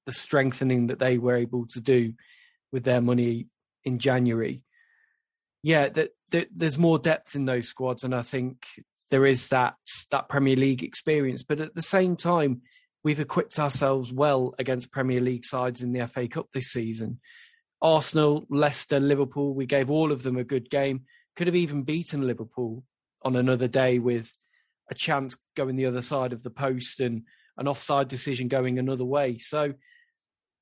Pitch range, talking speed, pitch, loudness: 125-150 Hz, 170 wpm, 135 Hz, -26 LUFS